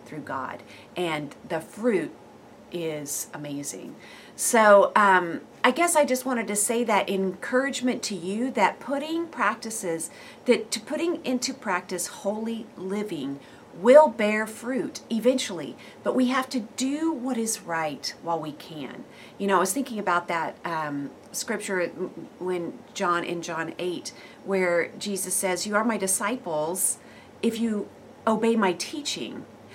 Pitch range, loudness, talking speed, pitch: 175-250 Hz, -26 LUFS, 145 wpm, 205 Hz